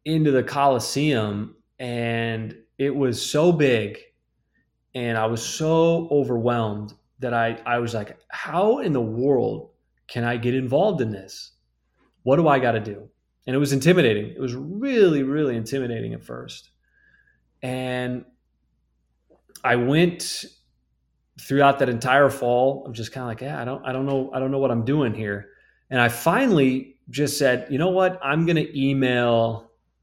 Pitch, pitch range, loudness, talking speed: 125 Hz, 115-140 Hz, -22 LUFS, 165 wpm